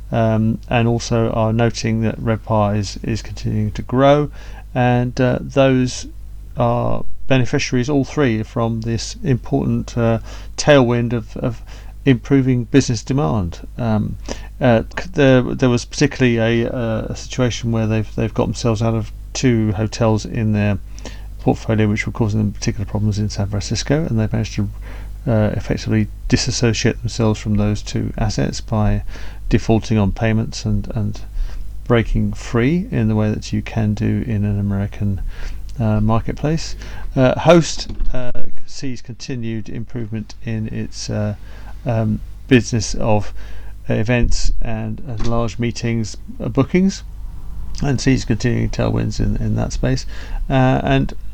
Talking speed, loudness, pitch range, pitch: 140 wpm, -19 LUFS, 105-120 Hz, 110 Hz